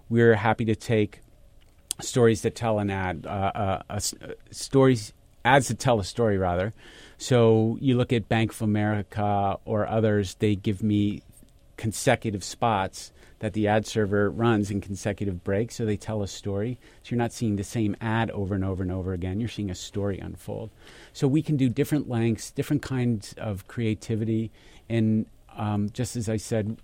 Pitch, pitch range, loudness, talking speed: 110 Hz, 100-115 Hz, -26 LUFS, 180 wpm